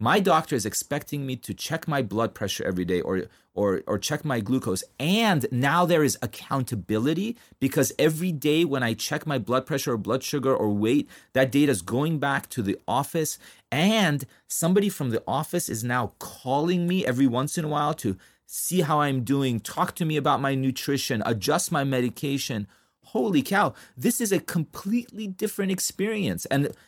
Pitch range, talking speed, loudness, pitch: 125-165 Hz, 185 wpm, -25 LUFS, 140 Hz